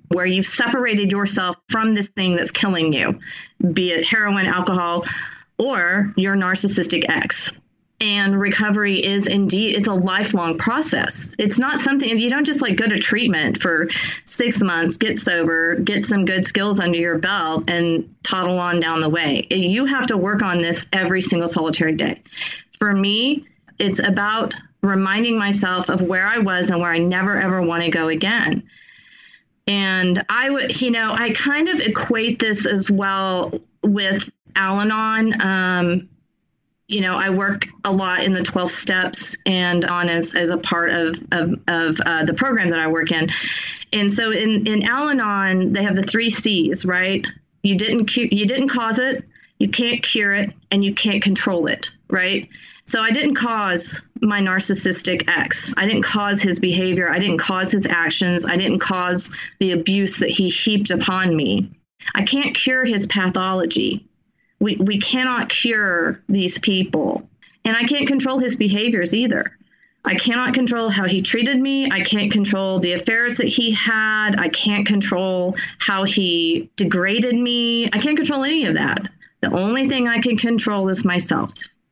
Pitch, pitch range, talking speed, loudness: 200 Hz, 180-225 Hz, 170 wpm, -19 LUFS